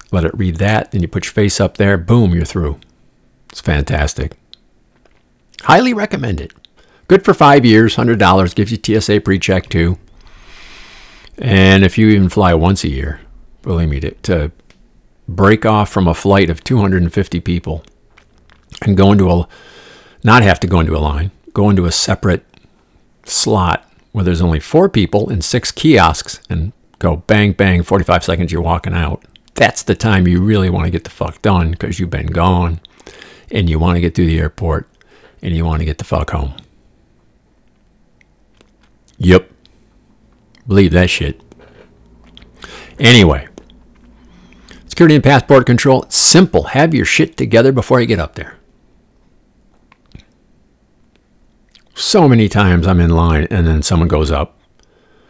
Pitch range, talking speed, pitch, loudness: 85-105 Hz, 155 wpm, 95 Hz, -12 LUFS